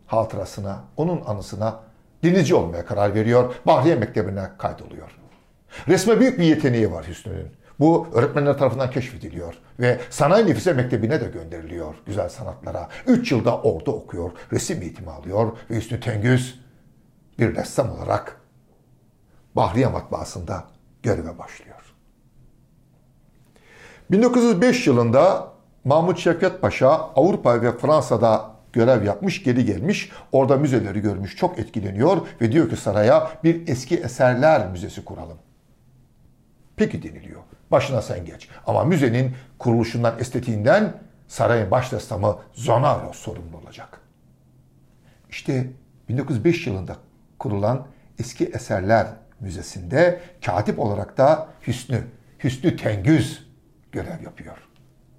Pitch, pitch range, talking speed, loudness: 125 Hz, 110-150 Hz, 110 wpm, -21 LUFS